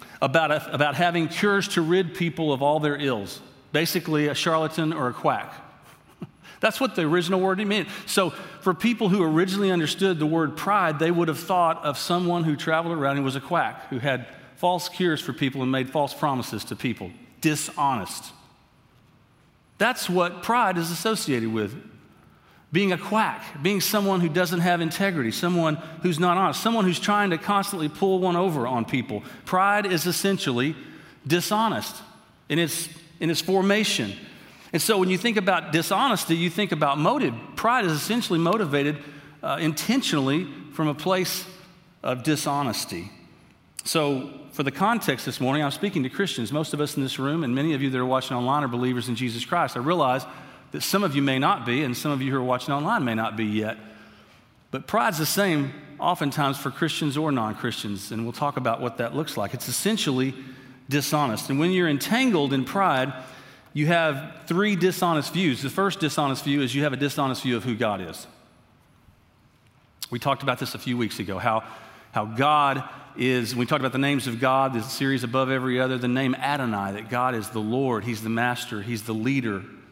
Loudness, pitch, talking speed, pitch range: -24 LUFS, 150 Hz, 190 wpm, 130-180 Hz